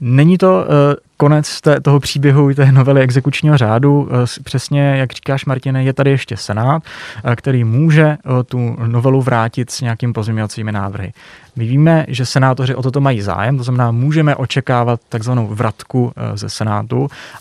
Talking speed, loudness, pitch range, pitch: 150 wpm, -14 LUFS, 120-140 Hz, 130 Hz